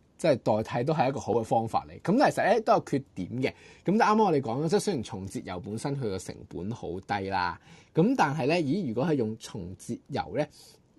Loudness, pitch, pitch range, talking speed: -28 LUFS, 115 Hz, 100-140 Hz, 335 characters per minute